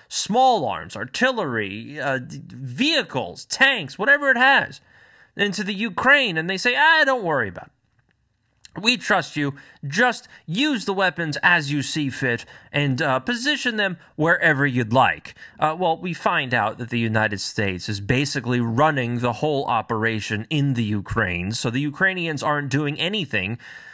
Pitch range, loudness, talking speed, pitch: 125-205 Hz, -21 LUFS, 155 wpm, 150 Hz